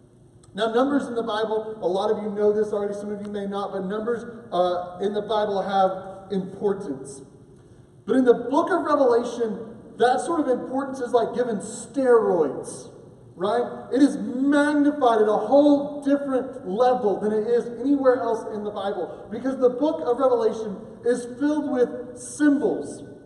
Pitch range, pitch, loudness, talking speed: 205-255 Hz, 230 Hz, -23 LUFS, 170 wpm